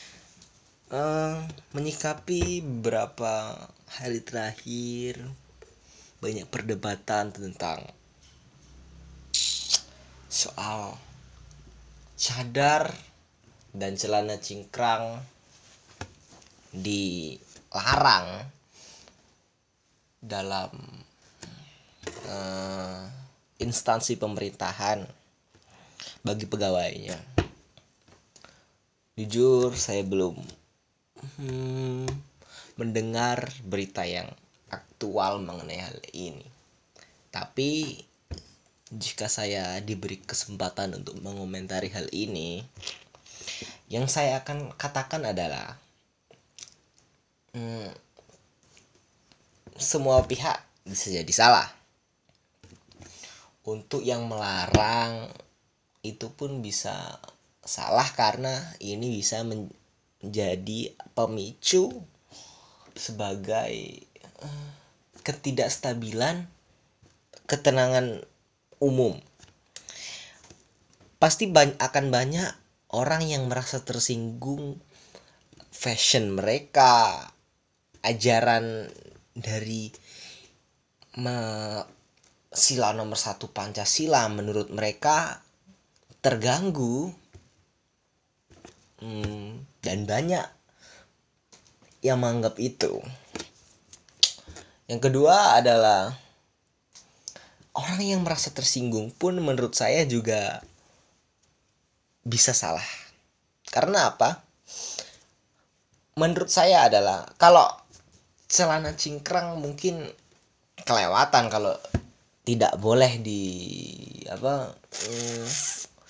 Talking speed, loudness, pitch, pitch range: 65 wpm, -26 LUFS, 115 Hz, 100-135 Hz